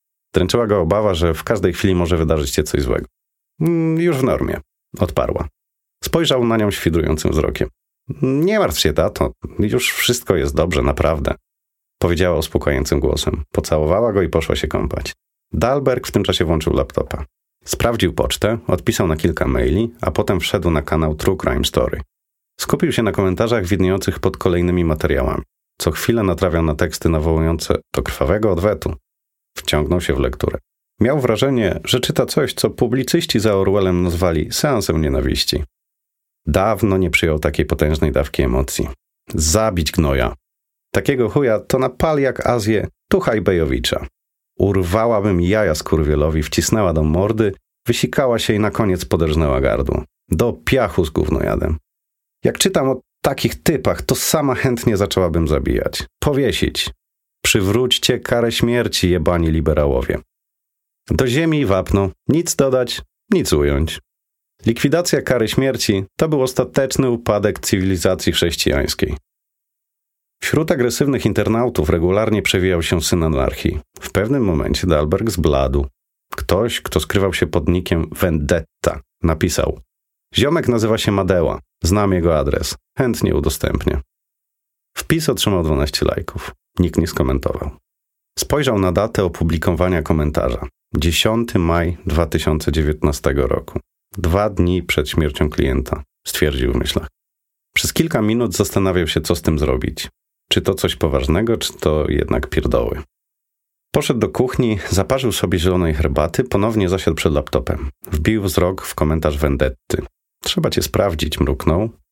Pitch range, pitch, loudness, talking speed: 80-110 Hz, 90 Hz, -18 LUFS, 135 wpm